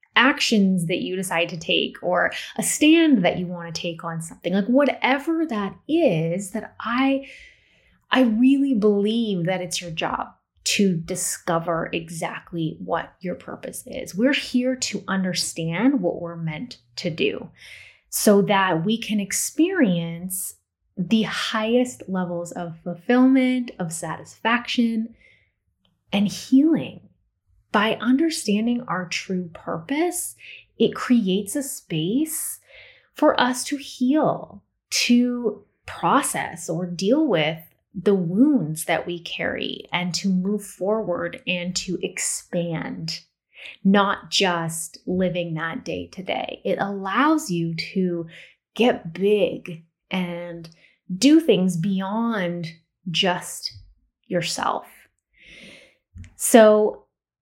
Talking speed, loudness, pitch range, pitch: 115 wpm, -22 LUFS, 170-245 Hz, 190 Hz